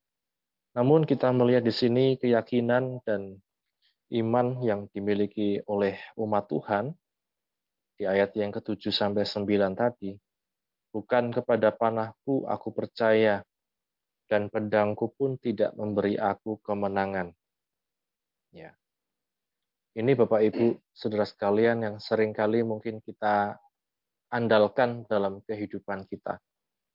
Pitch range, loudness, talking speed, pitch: 100-120 Hz, -27 LUFS, 100 wpm, 110 Hz